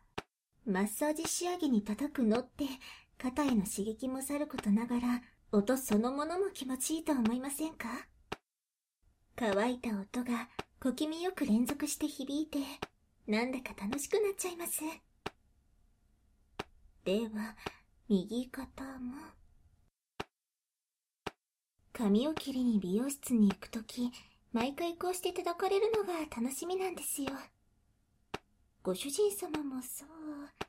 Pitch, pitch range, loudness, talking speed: 265 Hz, 230-310 Hz, -35 LUFS, 235 characters per minute